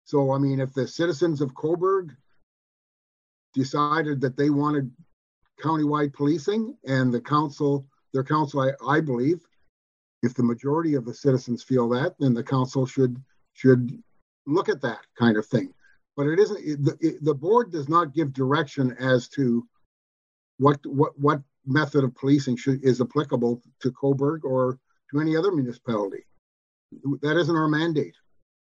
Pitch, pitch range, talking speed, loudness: 140 Hz, 125-150 Hz, 155 wpm, -24 LUFS